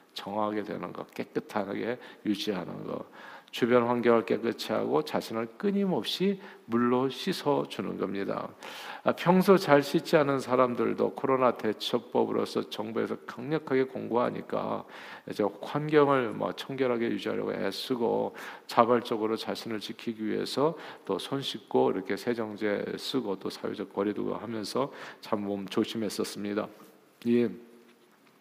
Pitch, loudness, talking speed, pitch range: 120 Hz, -29 LUFS, 295 characters per minute, 110-135 Hz